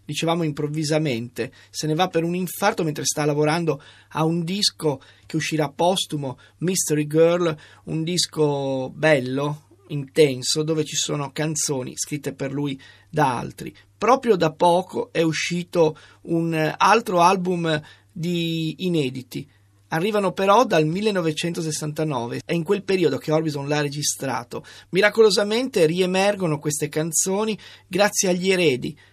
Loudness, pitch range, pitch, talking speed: -22 LUFS, 145-175 Hz, 155 Hz, 125 wpm